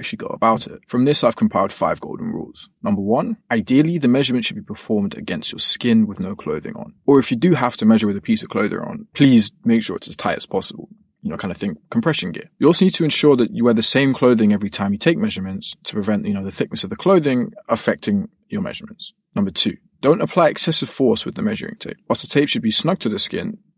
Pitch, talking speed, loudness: 180 Hz, 255 wpm, -18 LUFS